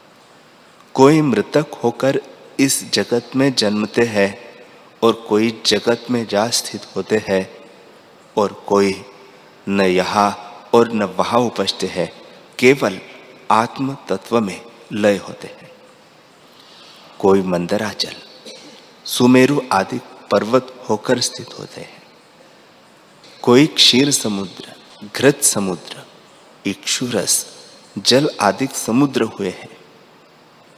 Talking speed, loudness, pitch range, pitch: 100 wpm, -17 LUFS, 100-125 Hz, 110 Hz